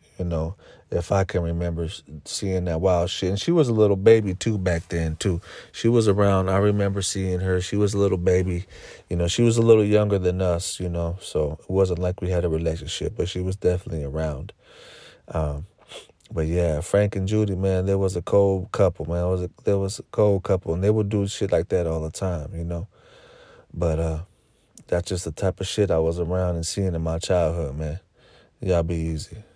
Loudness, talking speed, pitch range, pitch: -23 LUFS, 220 wpm, 85-100 Hz, 90 Hz